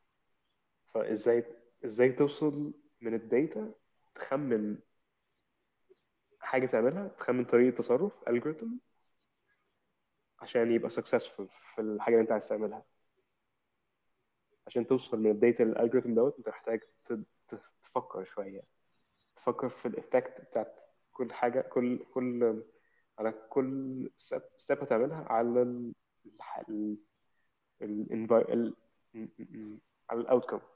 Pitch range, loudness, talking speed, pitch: 110-130 Hz, -32 LUFS, 110 wpm, 120 Hz